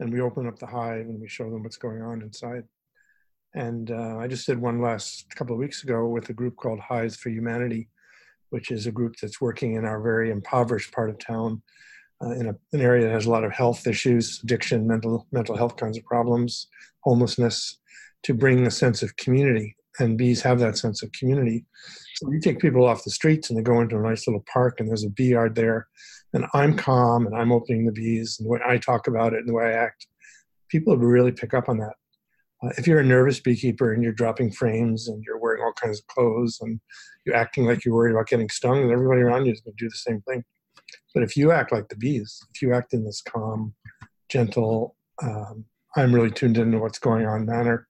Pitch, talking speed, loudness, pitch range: 120 Hz, 230 wpm, -24 LUFS, 115-125 Hz